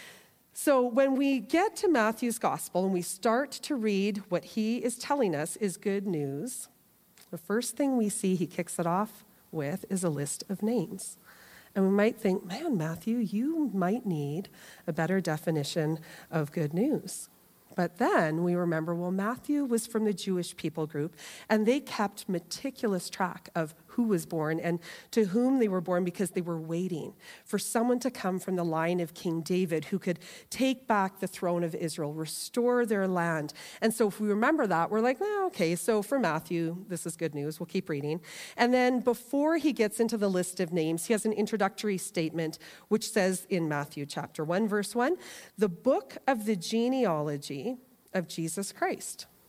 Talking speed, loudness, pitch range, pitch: 185 wpm, -30 LUFS, 170-230 Hz, 195 Hz